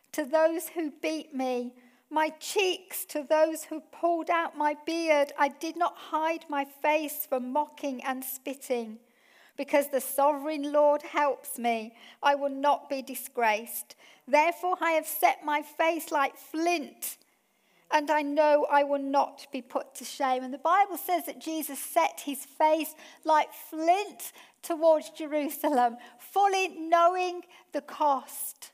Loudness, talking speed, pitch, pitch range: -28 LUFS, 145 wpm, 300 Hz, 275-320 Hz